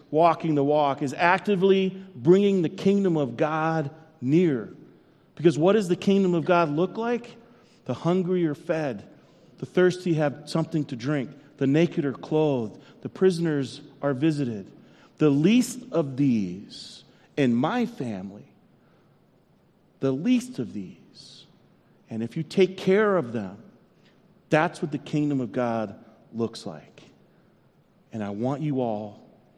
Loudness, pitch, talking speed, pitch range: -25 LUFS, 155 Hz, 140 wpm, 135-180 Hz